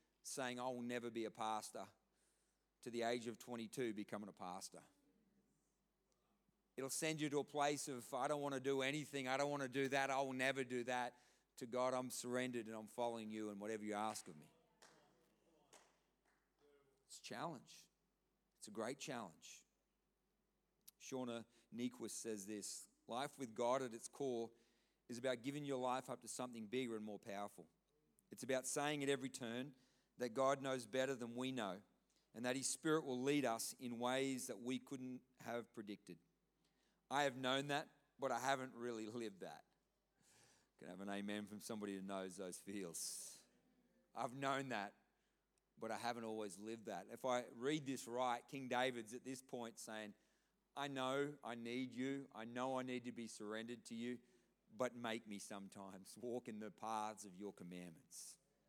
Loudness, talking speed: -46 LUFS, 180 wpm